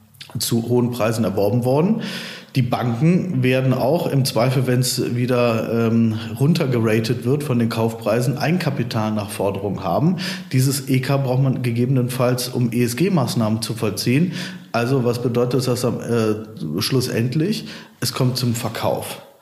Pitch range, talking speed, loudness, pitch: 115-135 Hz, 140 wpm, -20 LUFS, 125 Hz